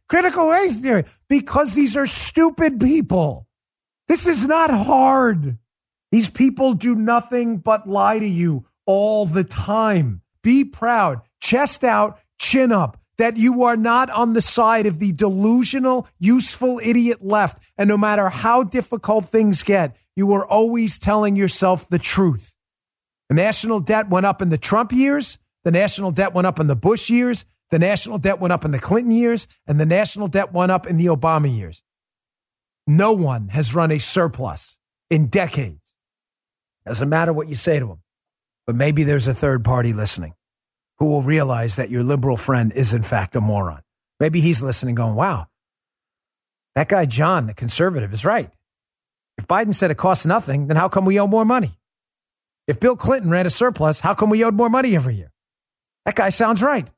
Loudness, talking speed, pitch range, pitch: -18 LUFS, 180 wpm, 140-230 Hz, 190 Hz